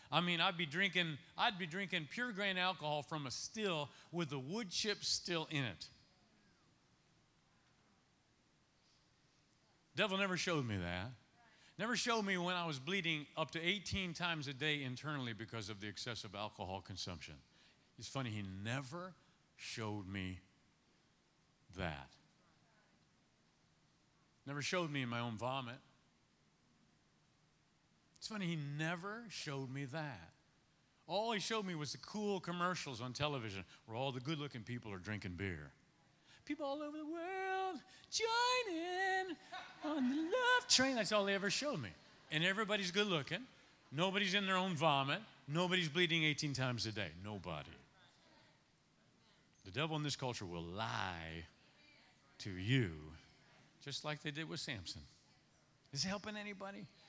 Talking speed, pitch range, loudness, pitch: 145 wpm, 120-195 Hz, -40 LUFS, 155 Hz